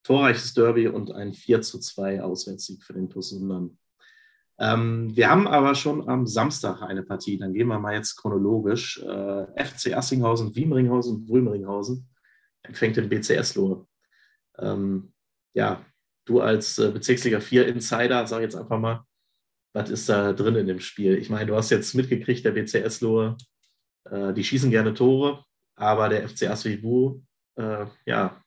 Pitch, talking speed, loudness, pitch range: 110 Hz, 155 wpm, -24 LUFS, 100-125 Hz